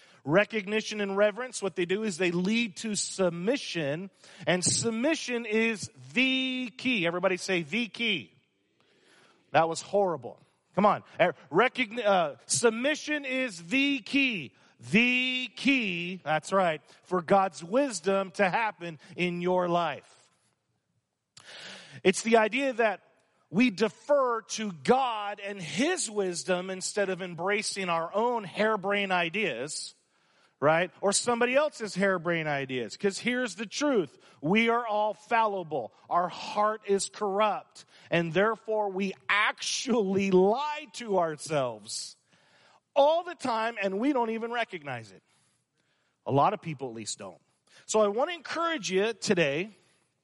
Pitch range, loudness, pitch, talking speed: 180-235 Hz, -28 LUFS, 205 Hz, 130 wpm